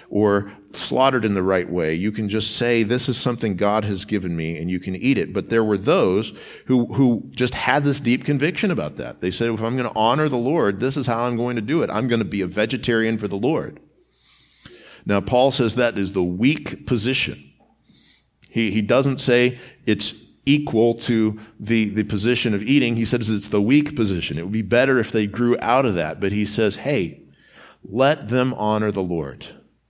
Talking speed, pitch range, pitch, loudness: 215 wpm, 105-125 Hz, 115 Hz, -21 LUFS